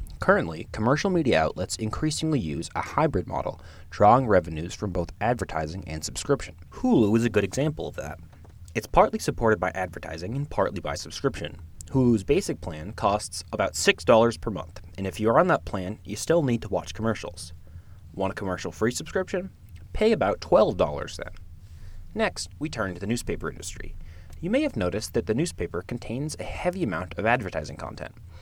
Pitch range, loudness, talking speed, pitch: 85-120 Hz, -26 LUFS, 175 wpm, 100 Hz